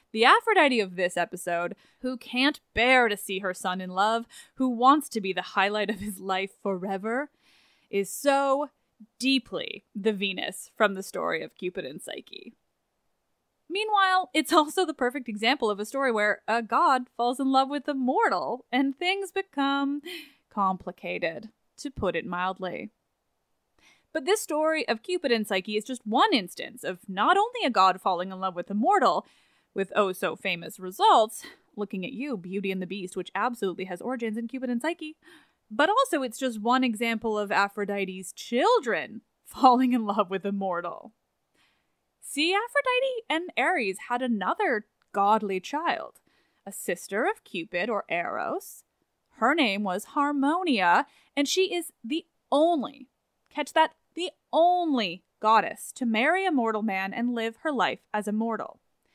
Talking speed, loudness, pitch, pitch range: 160 wpm, -26 LUFS, 235 Hz, 200-295 Hz